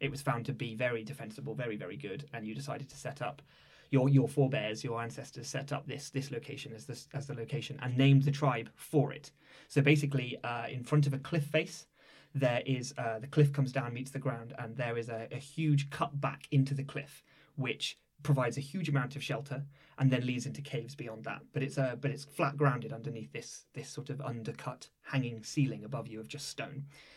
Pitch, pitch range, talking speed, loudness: 140 Hz, 125-145 Hz, 225 wpm, -35 LUFS